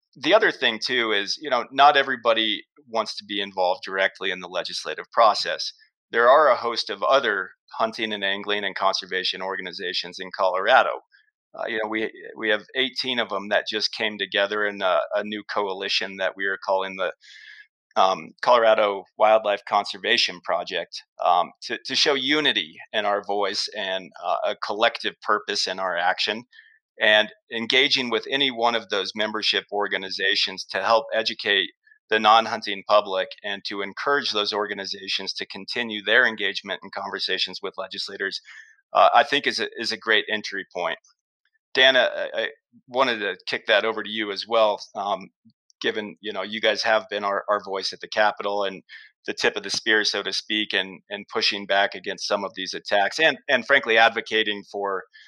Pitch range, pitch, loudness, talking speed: 100-115 Hz, 105 Hz, -23 LUFS, 175 wpm